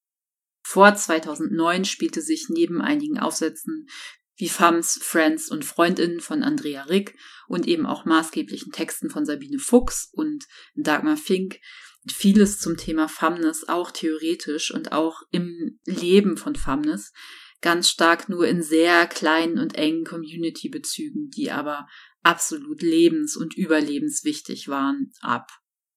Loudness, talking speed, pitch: -22 LUFS, 130 wpm, 190 Hz